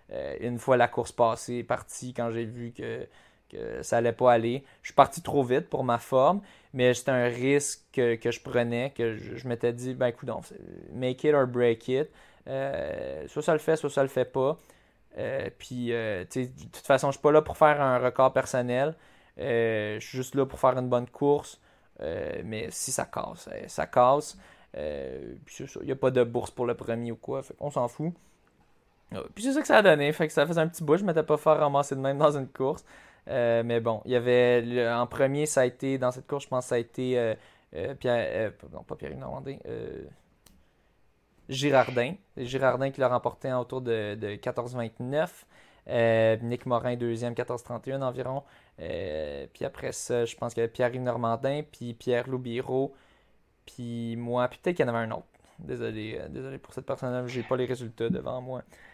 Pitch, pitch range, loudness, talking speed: 125 Hz, 120-135 Hz, -28 LUFS, 215 wpm